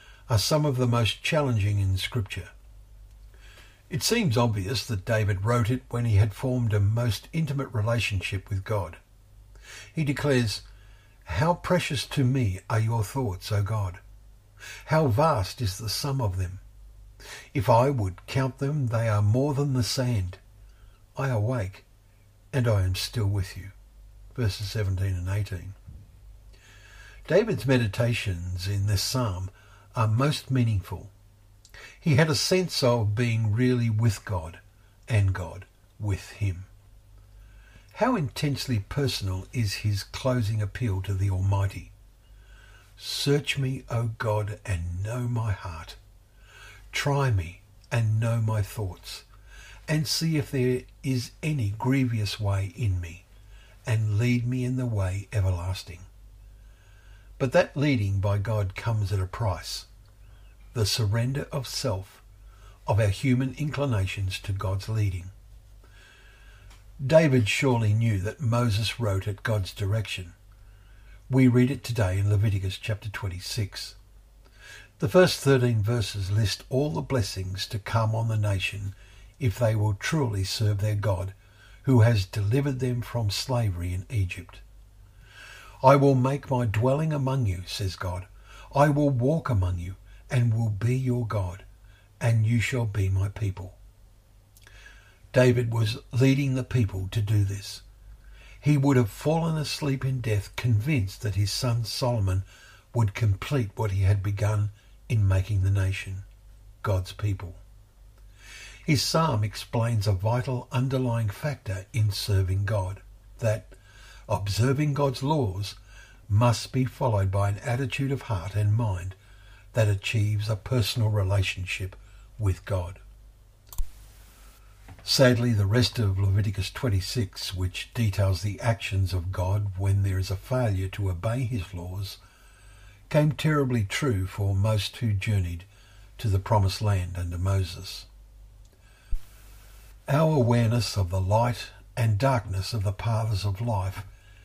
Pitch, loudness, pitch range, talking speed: 105 Hz, -26 LUFS, 100-120 Hz, 135 wpm